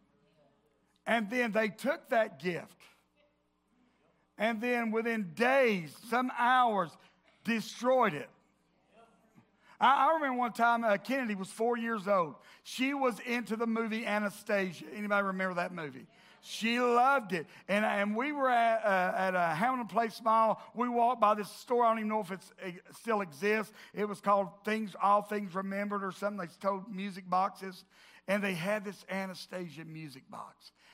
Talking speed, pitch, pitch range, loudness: 160 wpm, 210 Hz, 190-230 Hz, -31 LUFS